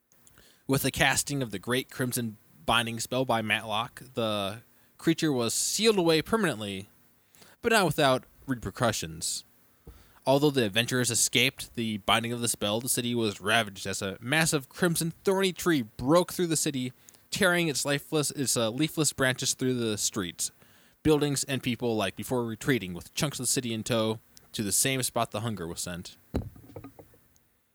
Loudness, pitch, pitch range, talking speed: -28 LUFS, 120 Hz, 110-140 Hz, 160 wpm